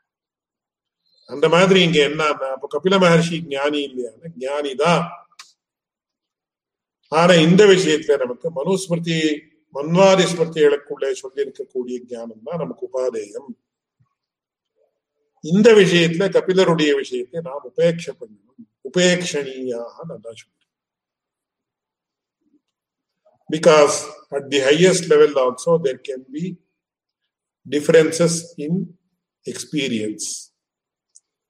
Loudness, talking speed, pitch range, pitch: -17 LUFS, 55 wpm, 145-235 Hz, 170 Hz